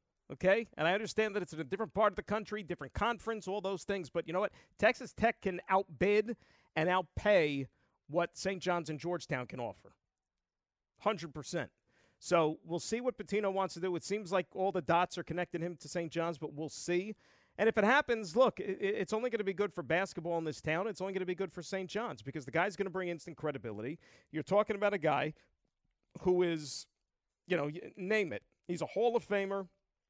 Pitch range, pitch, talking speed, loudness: 165-205 Hz, 185 Hz, 215 wpm, -35 LUFS